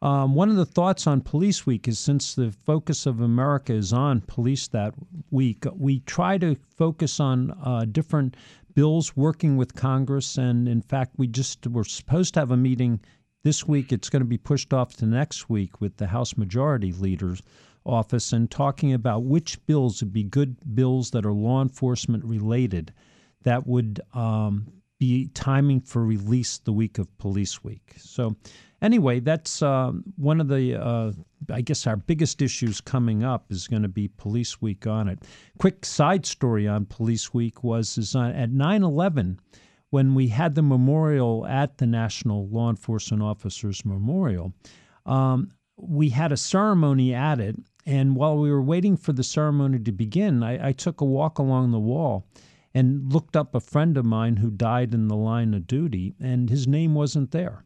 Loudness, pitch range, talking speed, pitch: -24 LUFS, 115-145 Hz, 180 wpm, 130 Hz